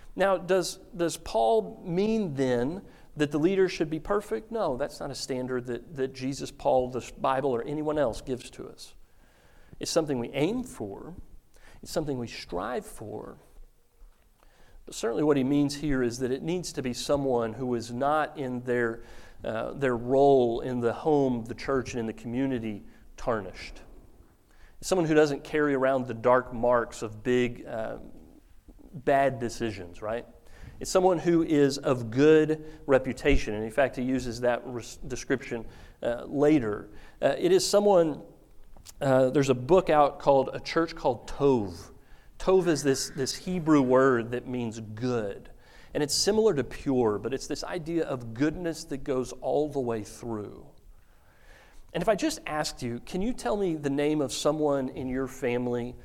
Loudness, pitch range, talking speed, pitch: -28 LUFS, 120-155 Hz, 170 wpm, 135 Hz